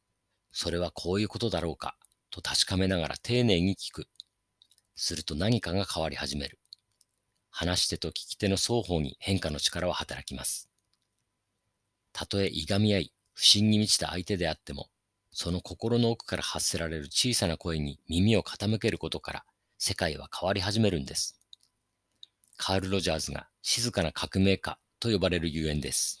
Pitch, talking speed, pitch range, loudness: 95 Hz, 320 characters per minute, 85-105 Hz, -29 LUFS